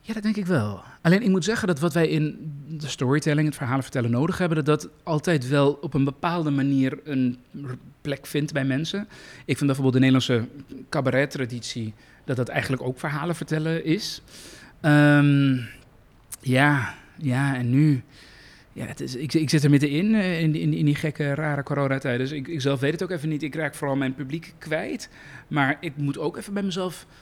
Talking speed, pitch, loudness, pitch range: 195 wpm, 145 Hz, -24 LUFS, 135-160 Hz